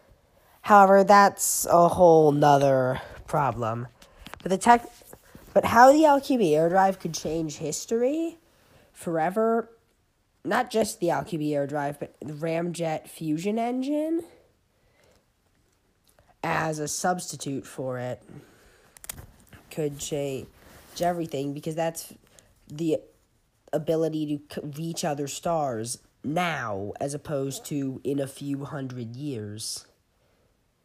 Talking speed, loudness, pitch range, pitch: 105 wpm, -25 LUFS, 140-180 Hz, 155 Hz